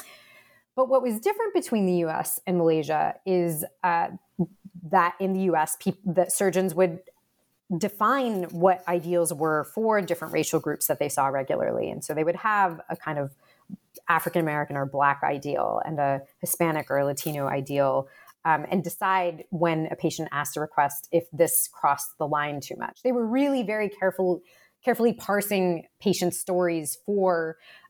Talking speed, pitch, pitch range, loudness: 165 wpm, 175 Hz, 155-195 Hz, -26 LUFS